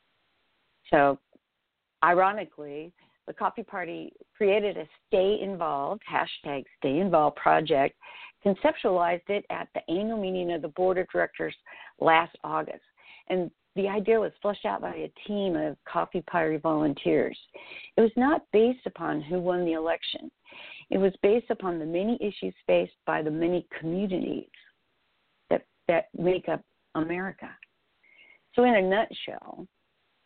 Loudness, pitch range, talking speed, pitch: -27 LUFS, 170-210 Hz, 135 wpm, 185 Hz